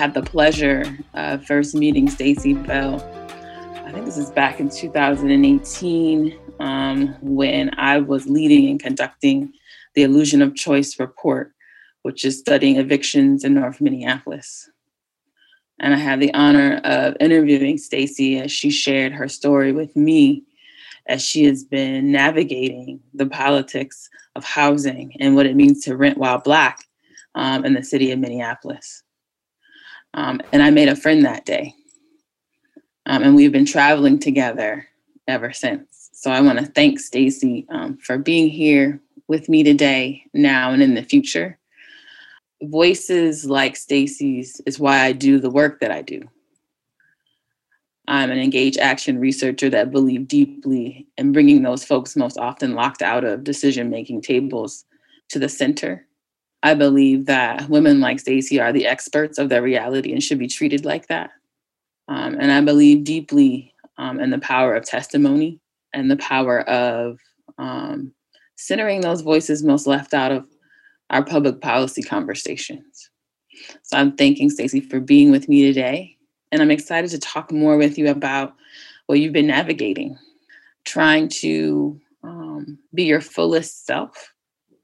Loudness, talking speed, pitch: -17 LUFS, 150 wpm, 155 Hz